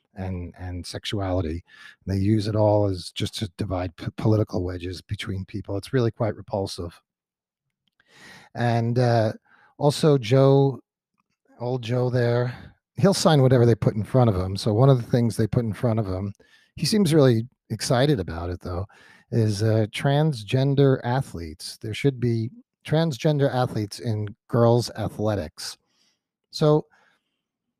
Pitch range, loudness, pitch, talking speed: 100-130 Hz, -23 LUFS, 115 Hz, 145 wpm